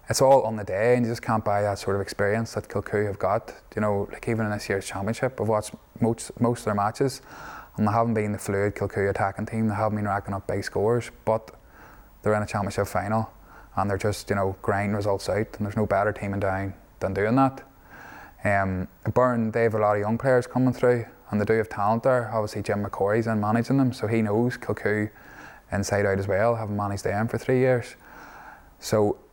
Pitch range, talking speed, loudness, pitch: 100-115 Hz, 230 wpm, -25 LUFS, 105 Hz